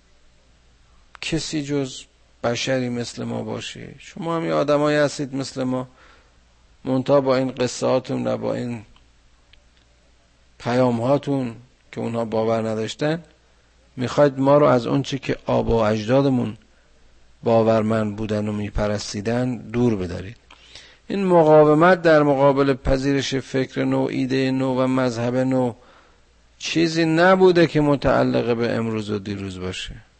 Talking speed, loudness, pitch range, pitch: 115 wpm, -21 LUFS, 100-140 Hz, 125 Hz